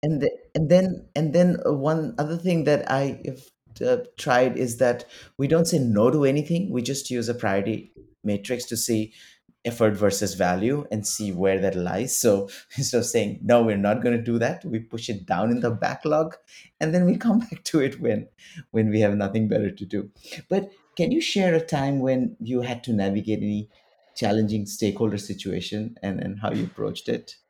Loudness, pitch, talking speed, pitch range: -24 LUFS, 120 Hz, 200 wpm, 110-155 Hz